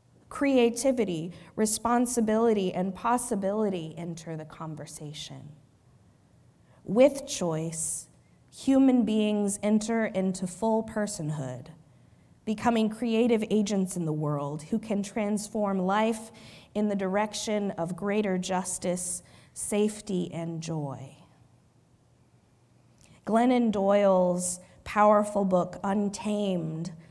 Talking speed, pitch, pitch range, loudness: 85 wpm, 200 Hz, 165-215 Hz, -28 LUFS